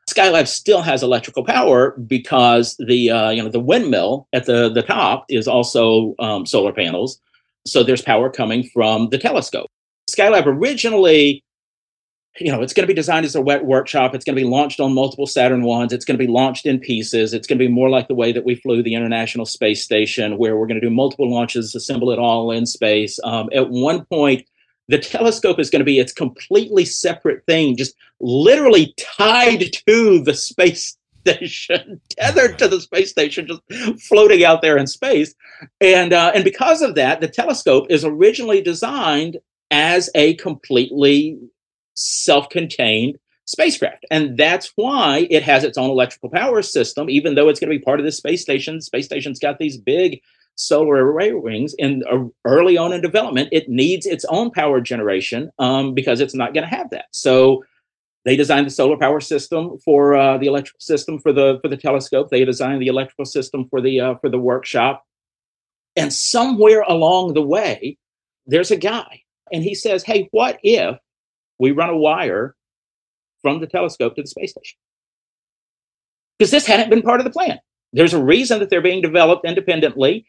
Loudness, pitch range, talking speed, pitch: -16 LUFS, 130-185 Hz, 190 wpm, 145 Hz